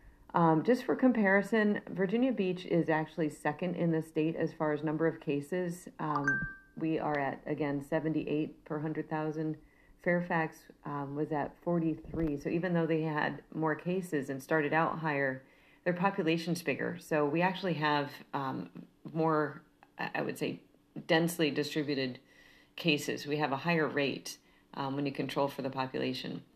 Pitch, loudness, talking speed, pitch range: 155 Hz, -33 LUFS, 155 wpm, 145-170 Hz